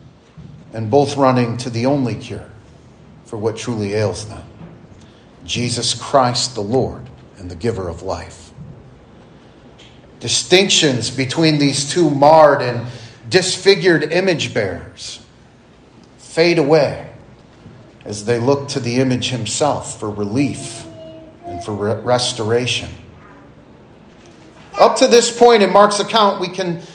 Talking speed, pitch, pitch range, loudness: 120 wpm, 125 Hz, 115-155 Hz, -16 LUFS